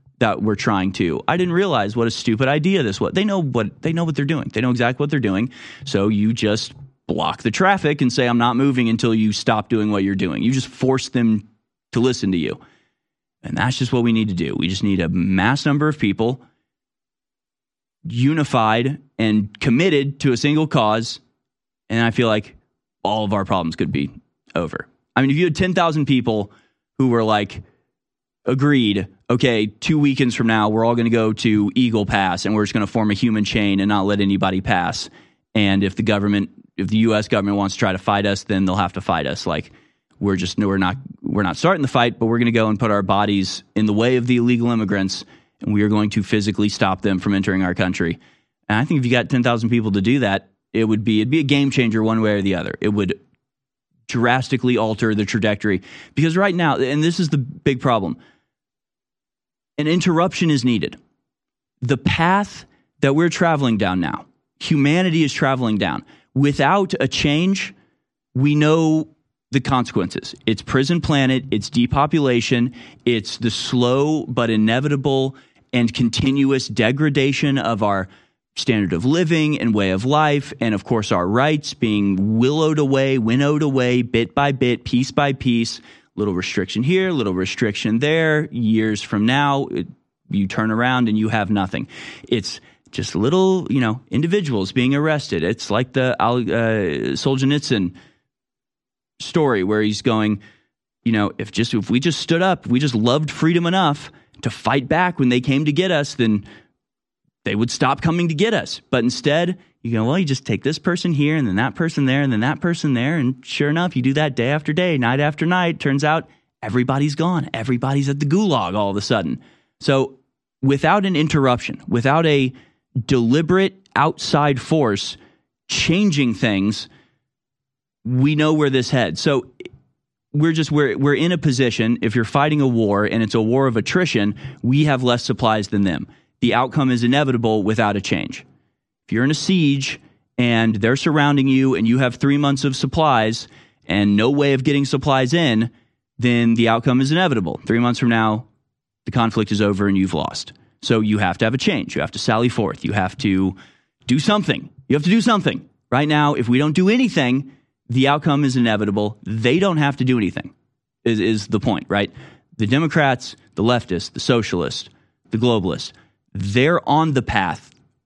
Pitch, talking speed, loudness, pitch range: 125 Hz, 190 wpm, -19 LUFS, 110-145 Hz